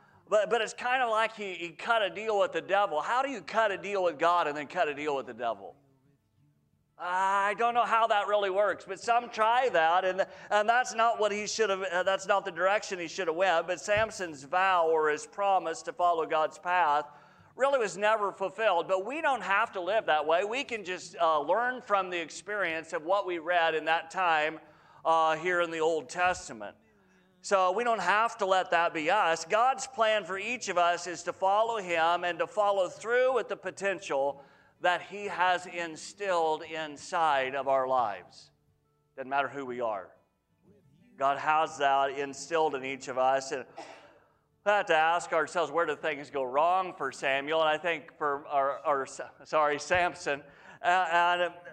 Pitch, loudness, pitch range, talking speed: 175 Hz, -29 LUFS, 155-205 Hz, 195 wpm